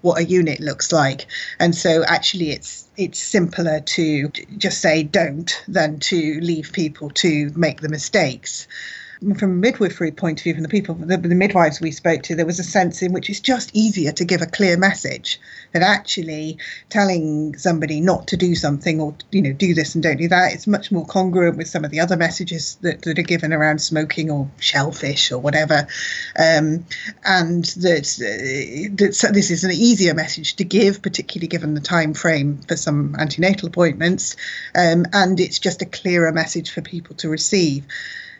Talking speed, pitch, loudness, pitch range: 190 wpm, 170 Hz, -19 LUFS, 155-185 Hz